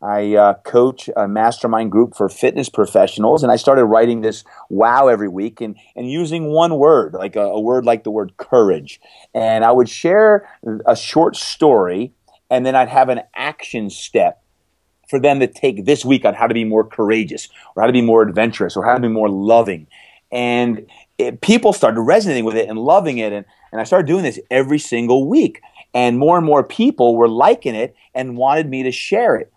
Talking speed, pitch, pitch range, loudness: 205 wpm, 120 Hz, 110-135 Hz, -15 LUFS